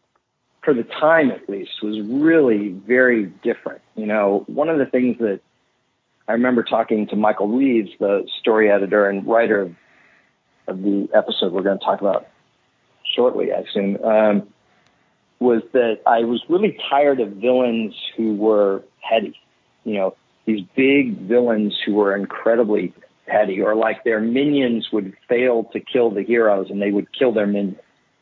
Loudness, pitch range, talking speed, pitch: -19 LUFS, 100-120 Hz, 160 wpm, 110 Hz